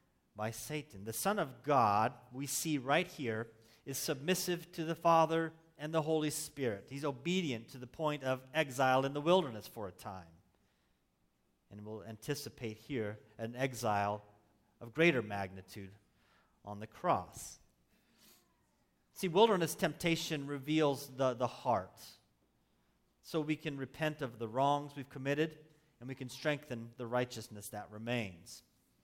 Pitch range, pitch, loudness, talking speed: 105-150 Hz, 125 Hz, -36 LUFS, 140 wpm